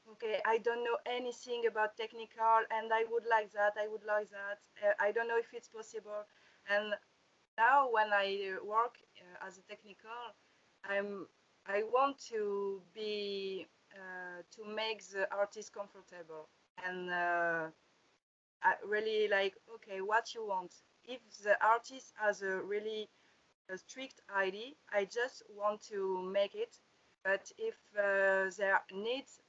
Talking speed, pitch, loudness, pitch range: 145 wpm, 210 Hz, -36 LUFS, 195-225 Hz